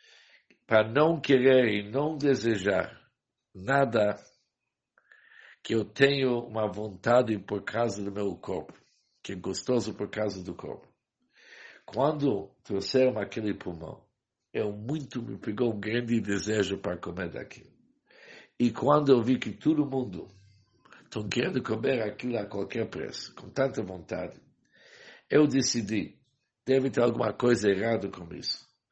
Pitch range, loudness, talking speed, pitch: 100-130 Hz, -28 LUFS, 135 wpm, 115 Hz